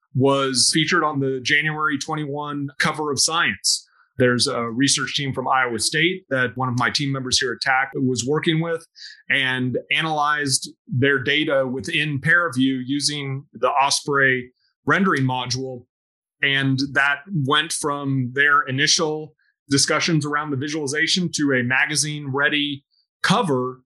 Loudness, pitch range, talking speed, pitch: -20 LUFS, 130-150 Hz, 135 wpm, 140 Hz